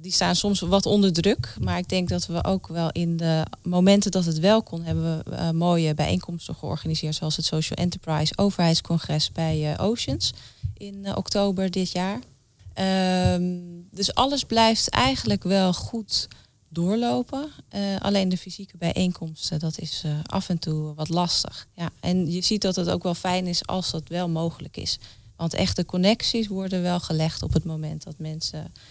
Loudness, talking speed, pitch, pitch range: -24 LUFS, 180 wpm, 175 Hz, 160-190 Hz